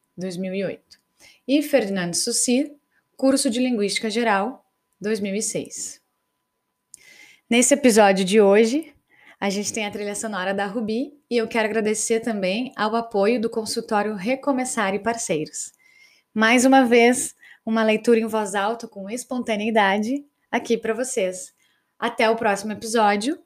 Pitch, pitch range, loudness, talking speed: 225 Hz, 210-255 Hz, -21 LUFS, 130 wpm